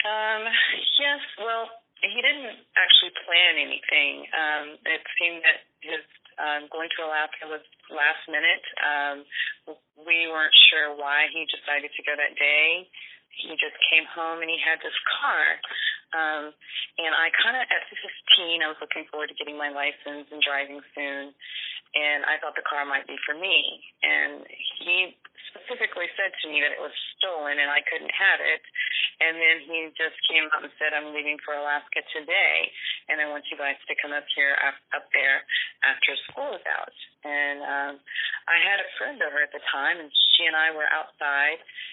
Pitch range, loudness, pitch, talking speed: 145-165 Hz, -23 LUFS, 155 Hz, 180 wpm